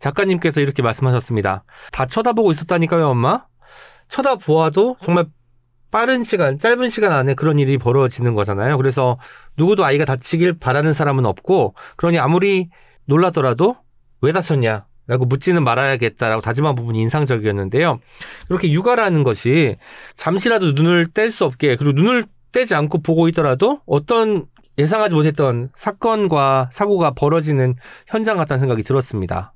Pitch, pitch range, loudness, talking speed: 150 Hz, 130-180 Hz, -17 LUFS, 375 characters per minute